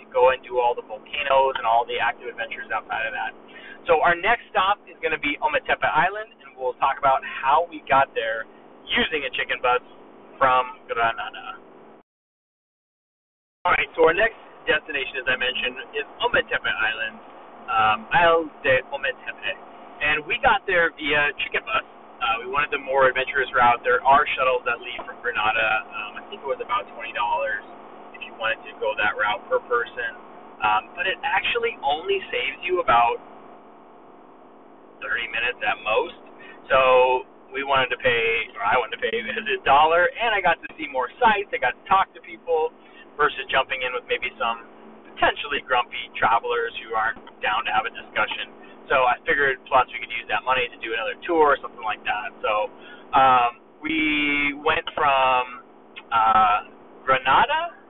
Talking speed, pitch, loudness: 170 wpm, 310 Hz, -22 LUFS